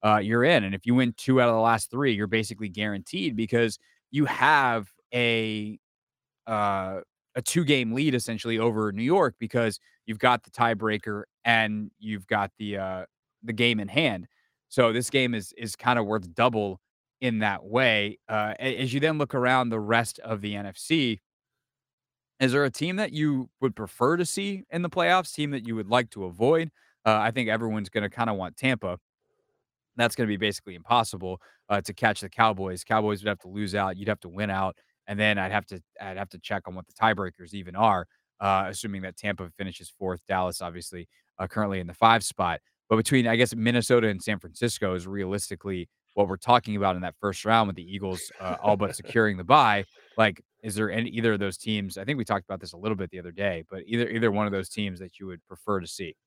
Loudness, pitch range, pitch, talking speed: -26 LUFS, 100-120 Hz, 110 Hz, 220 wpm